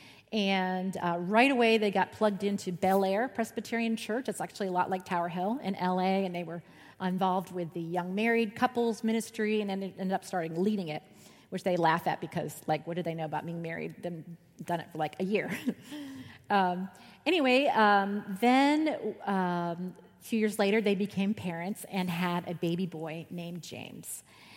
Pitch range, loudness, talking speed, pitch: 175-215 Hz, -30 LUFS, 190 wpm, 190 Hz